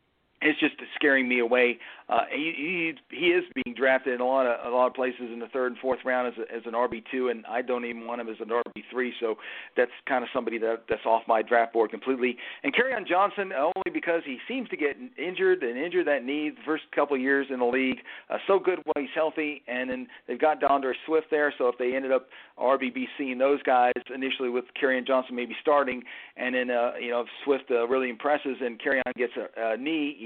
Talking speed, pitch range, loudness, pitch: 240 wpm, 120-150 Hz, -27 LUFS, 130 Hz